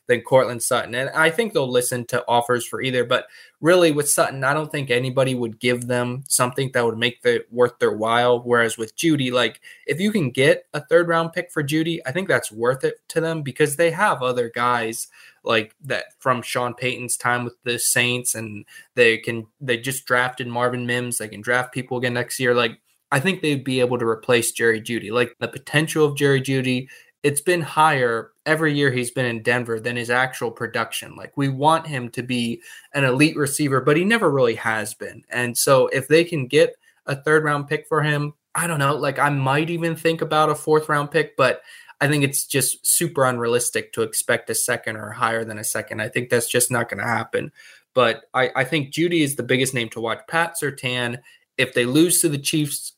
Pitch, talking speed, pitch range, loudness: 130 Hz, 220 wpm, 120-155 Hz, -21 LUFS